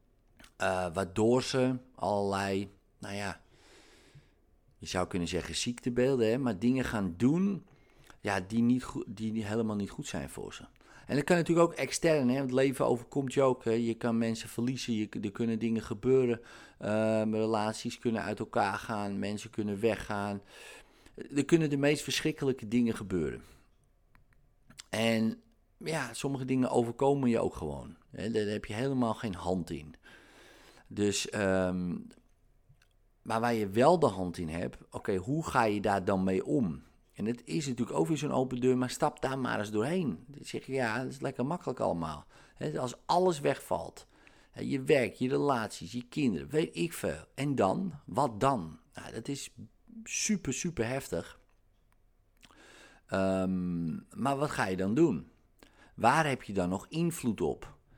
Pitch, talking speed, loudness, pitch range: 115 Hz, 170 wpm, -32 LUFS, 100-135 Hz